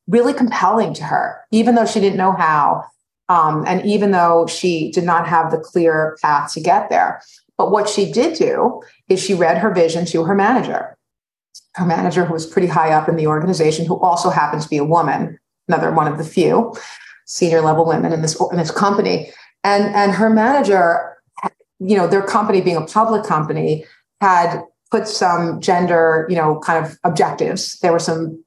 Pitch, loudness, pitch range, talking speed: 175 Hz, -16 LUFS, 165-205 Hz, 195 wpm